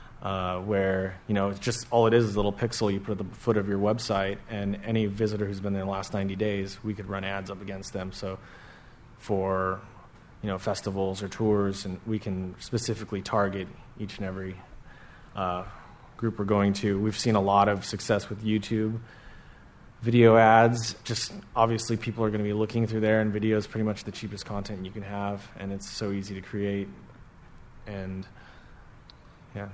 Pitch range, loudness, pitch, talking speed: 100-110 Hz, -28 LUFS, 105 Hz, 200 wpm